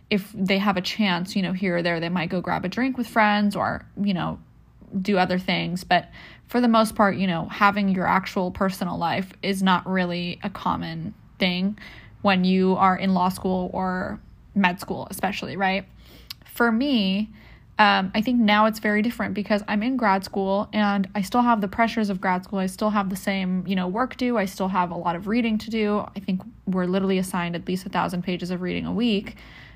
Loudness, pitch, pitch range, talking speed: -23 LUFS, 195 Hz, 185-210 Hz, 220 wpm